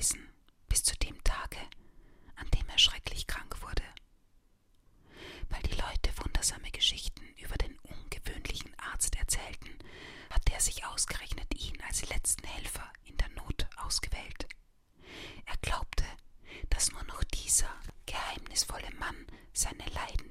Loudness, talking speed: -34 LUFS, 125 wpm